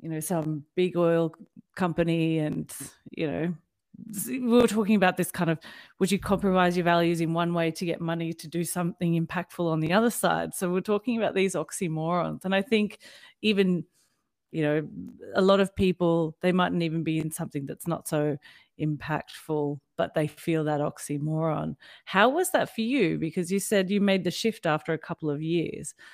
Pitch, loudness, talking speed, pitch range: 170 Hz, -27 LUFS, 190 wpm, 160-195 Hz